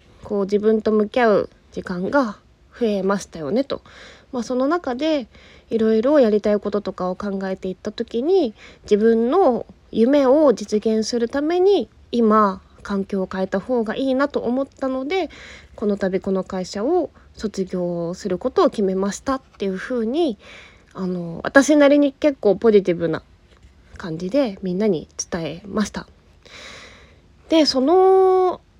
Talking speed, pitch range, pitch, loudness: 275 characters per minute, 190-265 Hz, 220 Hz, -20 LUFS